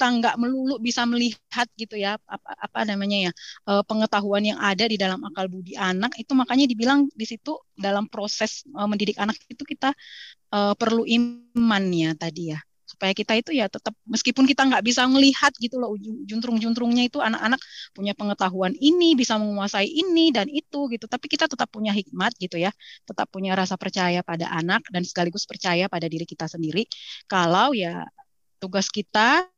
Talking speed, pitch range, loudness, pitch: 165 wpm, 195-250 Hz, -23 LUFS, 220 Hz